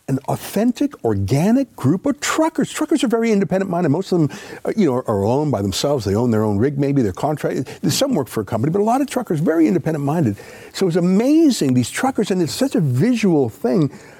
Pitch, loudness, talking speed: 170 Hz, -18 LUFS, 215 wpm